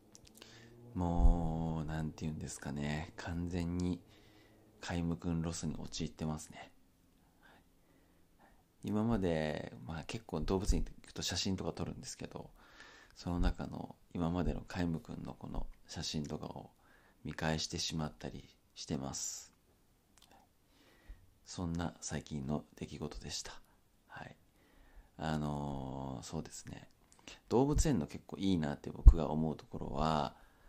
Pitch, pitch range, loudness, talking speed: 85 Hz, 75-90 Hz, -38 LUFS, 250 characters per minute